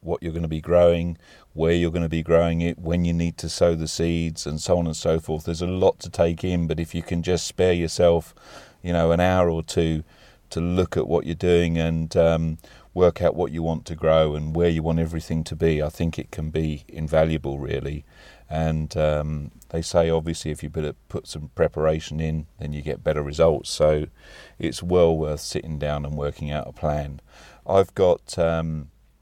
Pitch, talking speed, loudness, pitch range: 80 Hz, 215 wpm, -23 LUFS, 75-85 Hz